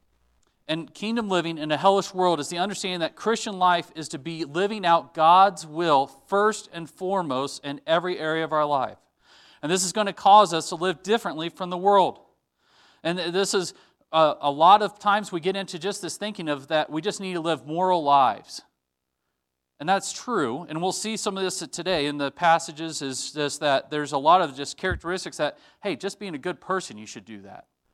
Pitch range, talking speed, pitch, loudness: 150-195 Hz, 210 wpm, 170 Hz, -24 LUFS